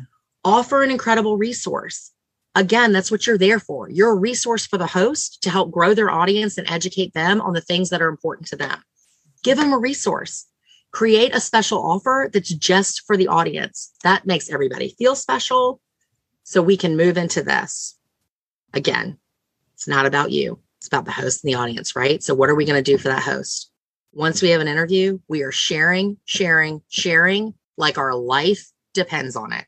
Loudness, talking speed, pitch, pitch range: -19 LUFS, 190 wpm, 185 Hz, 160-215 Hz